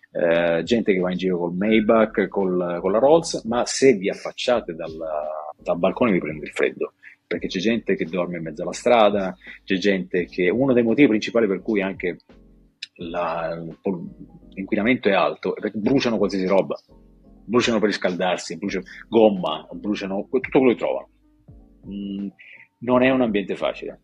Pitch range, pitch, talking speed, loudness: 90-120 Hz, 100 Hz, 170 wpm, -22 LUFS